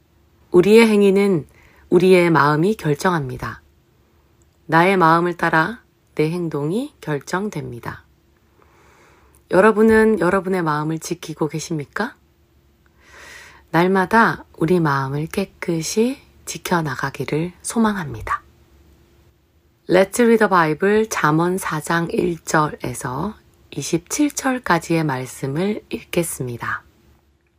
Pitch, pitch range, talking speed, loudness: 165 Hz, 140-190 Hz, 235 characters per minute, -19 LUFS